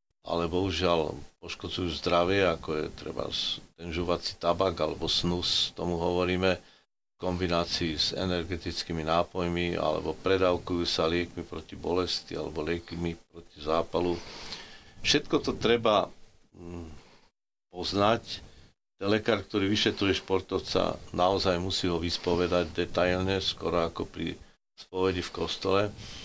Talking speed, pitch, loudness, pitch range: 110 wpm, 90 Hz, -29 LUFS, 85-95 Hz